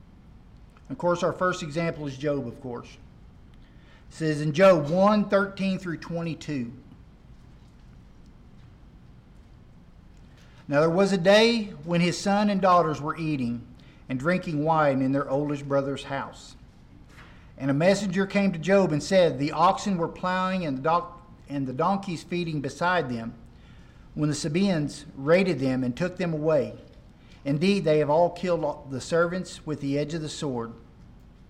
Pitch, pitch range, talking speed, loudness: 160 Hz, 140-180 Hz, 150 wpm, -25 LUFS